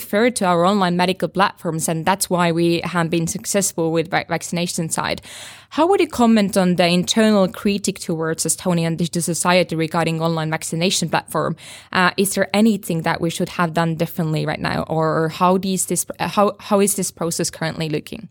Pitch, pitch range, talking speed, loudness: 175 Hz, 165-190 Hz, 175 wpm, -19 LUFS